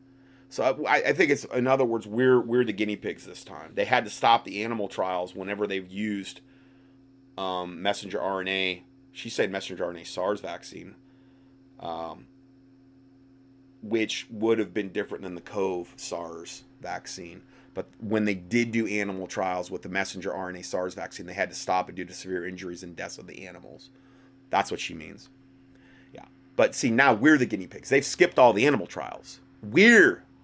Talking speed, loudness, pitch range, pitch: 180 wpm, -26 LUFS, 95-135 Hz, 110 Hz